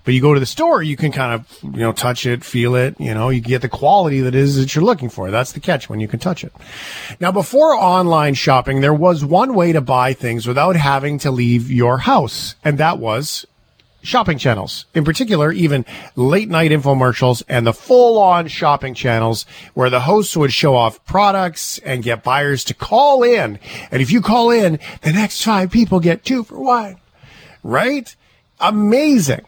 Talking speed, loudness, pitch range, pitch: 200 wpm, -15 LUFS, 125-185 Hz, 145 Hz